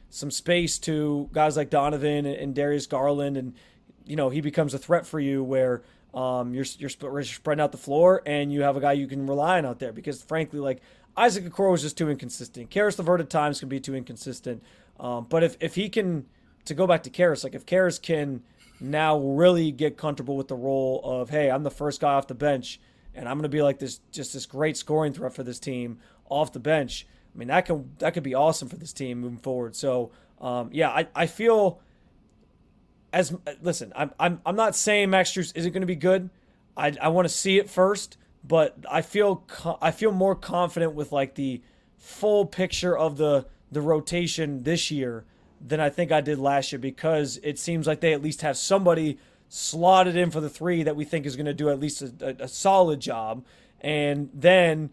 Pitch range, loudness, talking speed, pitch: 135-170 Hz, -25 LUFS, 220 wpm, 150 Hz